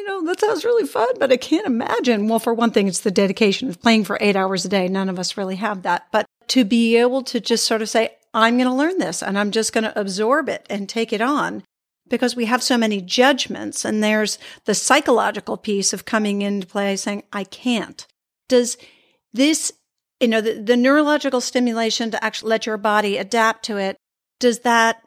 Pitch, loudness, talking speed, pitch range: 225 Hz, -19 LUFS, 215 wpm, 210-250 Hz